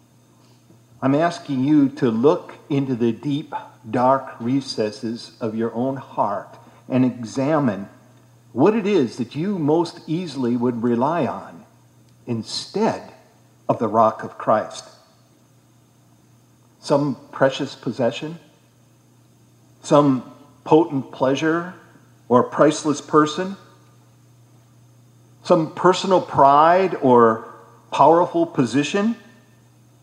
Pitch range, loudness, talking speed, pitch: 115-150 Hz, -20 LUFS, 95 wpm, 130 Hz